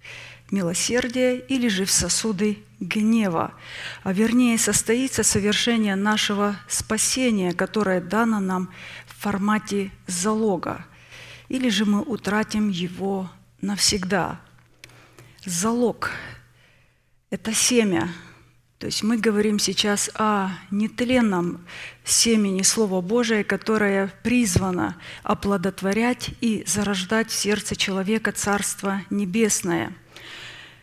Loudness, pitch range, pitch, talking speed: -22 LUFS, 190-220 Hz, 205 Hz, 95 wpm